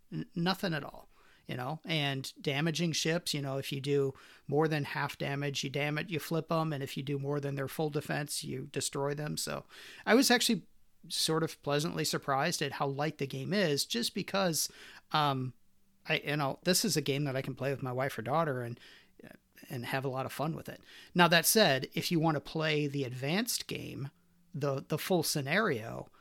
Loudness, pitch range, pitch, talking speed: -32 LUFS, 140-165 Hz, 150 Hz, 215 wpm